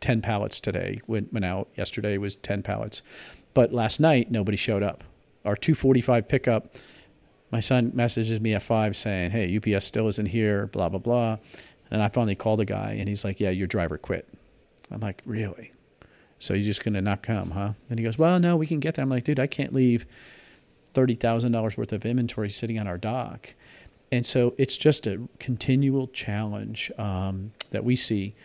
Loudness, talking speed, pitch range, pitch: -26 LUFS, 195 wpm, 105-125 Hz, 110 Hz